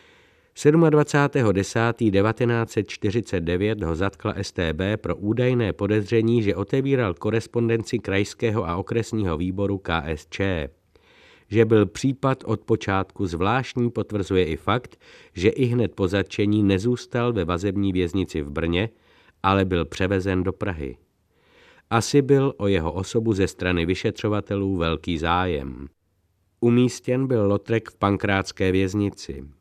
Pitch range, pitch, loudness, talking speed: 95-115 Hz, 100 Hz, -23 LUFS, 115 wpm